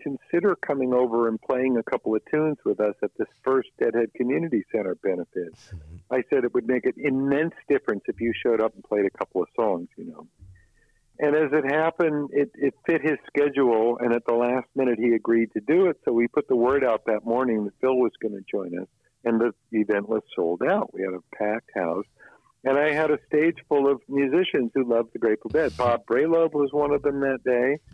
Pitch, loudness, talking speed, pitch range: 125 Hz, -24 LUFS, 225 wpm, 115-145 Hz